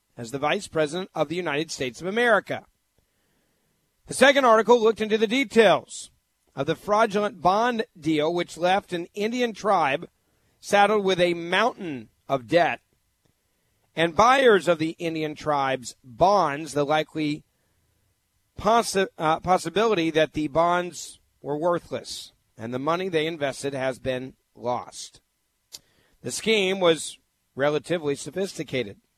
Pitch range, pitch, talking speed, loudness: 135-190 Hz, 160 Hz, 130 wpm, -23 LUFS